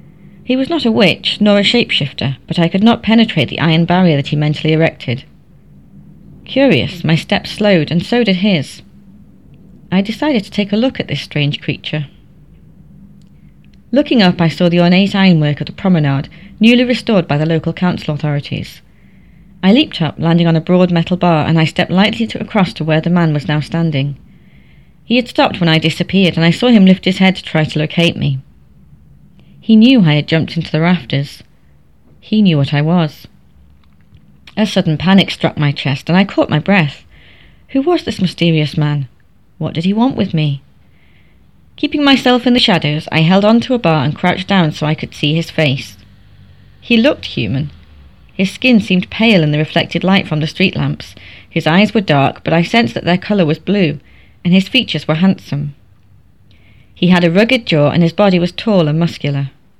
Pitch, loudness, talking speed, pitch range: 170 Hz, -13 LUFS, 195 wpm, 150-195 Hz